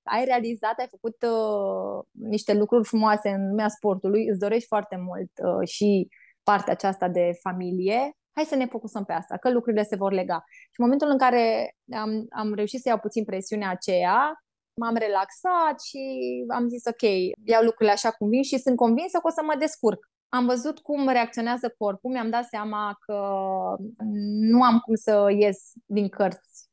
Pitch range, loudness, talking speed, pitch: 205-245 Hz, -25 LUFS, 180 wpm, 220 Hz